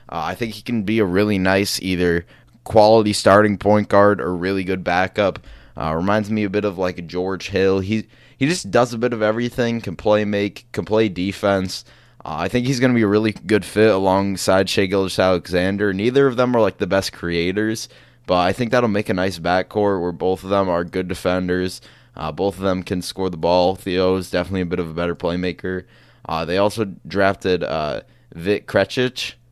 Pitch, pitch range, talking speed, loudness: 95 Hz, 90-110 Hz, 205 wpm, -19 LUFS